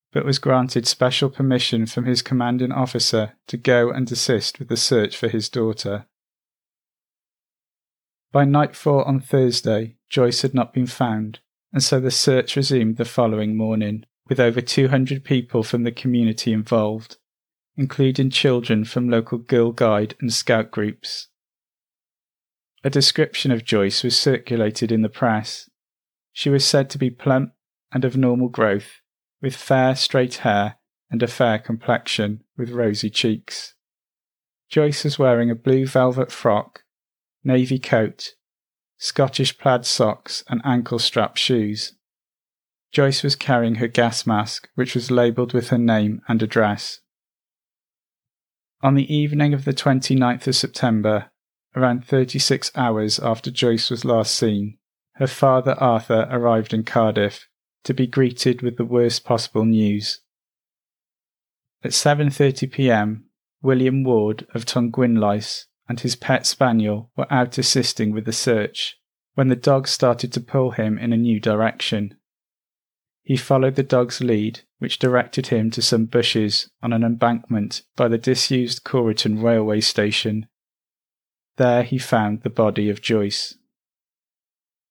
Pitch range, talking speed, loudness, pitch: 110-130 Hz, 140 wpm, -20 LUFS, 120 Hz